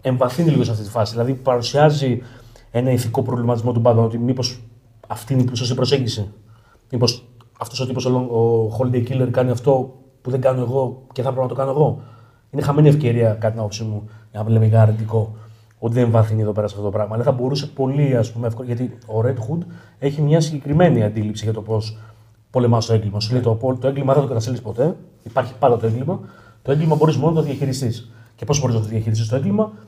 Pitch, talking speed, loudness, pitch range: 120 Hz, 220 wpm, -19 LUFS, 110-130 Hz